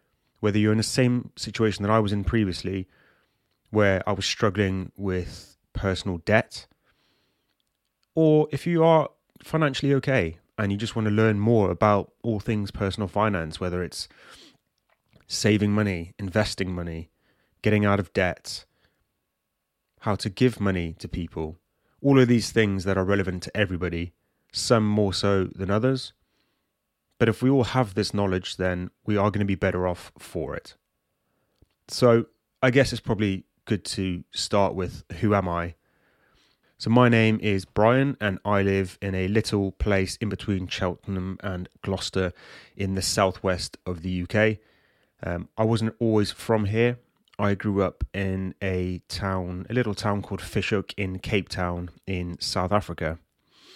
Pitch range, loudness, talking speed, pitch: 90-110 Hz, -25 LUFS, 155 wpm, 100 Hz